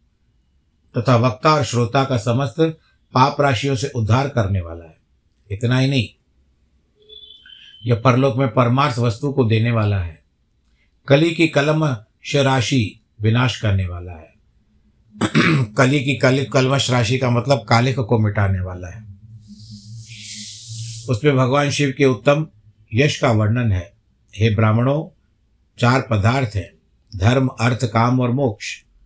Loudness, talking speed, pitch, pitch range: -18 LUFS, 130 wpm, 120 Hz, 105-135 Hz